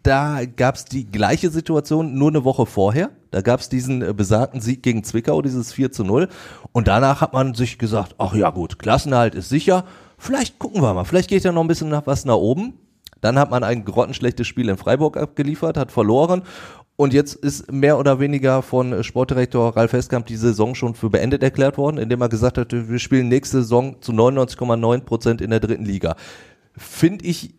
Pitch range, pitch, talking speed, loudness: 115-145 Hz, 125 Hz, 205 wpm, -19 LUFS